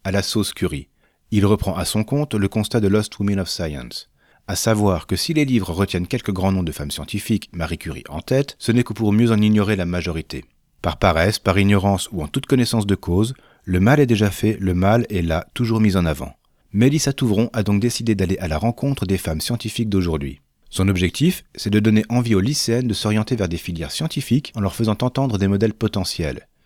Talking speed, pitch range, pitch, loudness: 225 wpm, 90-115 Hz, 100 Hz, -20 LUFS